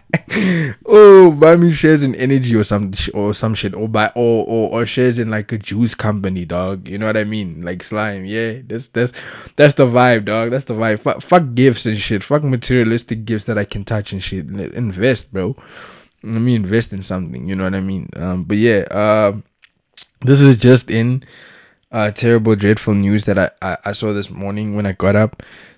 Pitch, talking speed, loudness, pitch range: 110 Hz, 210 wpm, -15 LUFS, 105-125 Hz